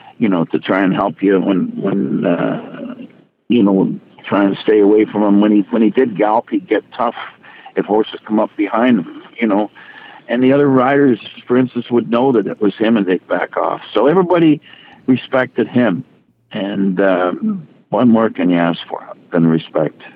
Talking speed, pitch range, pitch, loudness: 195 wpm, 105-150 Hz, 125 Hz, -15 LUFS